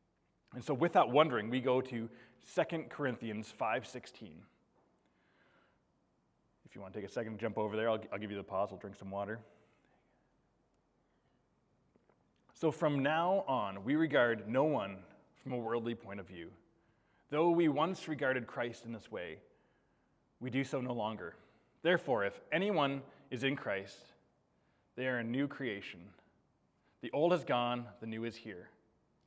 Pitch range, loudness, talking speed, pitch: 110-140 Hz, -36 LUFS, 160 wpm, 120 Hz